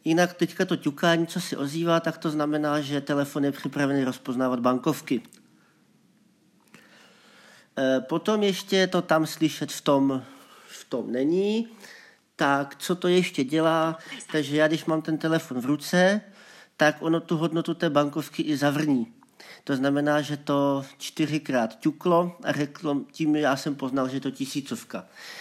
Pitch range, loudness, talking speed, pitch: 140-170 Hz, -25 LUFS, 150 wpm, 155 Hz